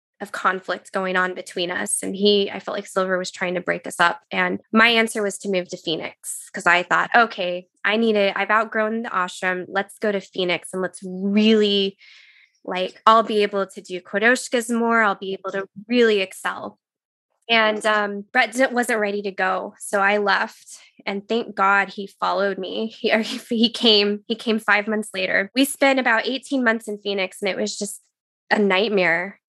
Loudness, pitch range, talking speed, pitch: -21 LUFS, 190-225 Hz, 195 wpm, 205 Hz